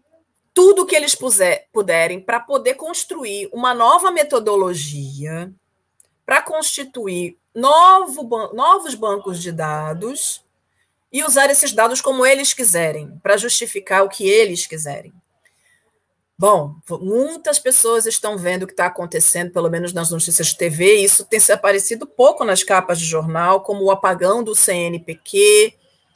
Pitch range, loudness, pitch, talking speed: 175-280 Hz, -14 LUFS, 210 Hz, 140 wpm